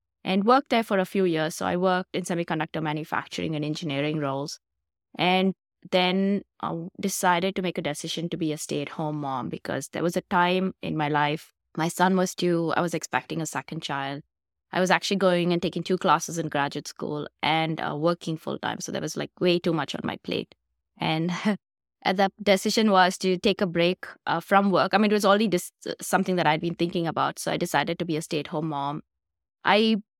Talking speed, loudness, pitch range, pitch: 215 wpm, -26 LUFS, 155-185 Hz, 175 Hz